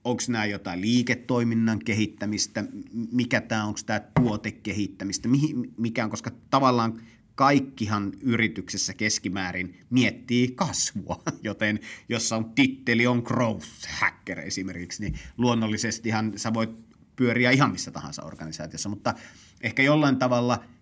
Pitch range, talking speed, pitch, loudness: 105-125 Hz, 120 wpm, 115 Hz, -26 LUFS